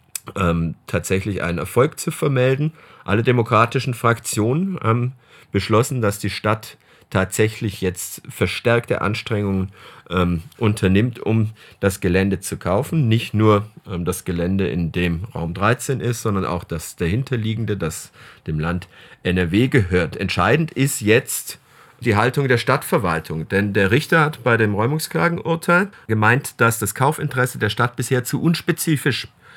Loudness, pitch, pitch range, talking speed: -20 LUFS, 110 Hz, 95-130 Hz, 140 wpm